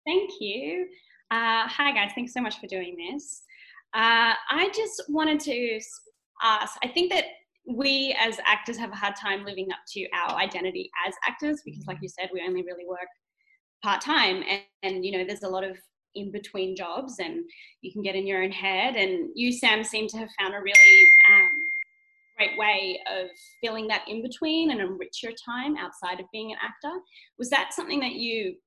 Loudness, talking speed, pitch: -22 LUFS, 195 wpm, 235 Hz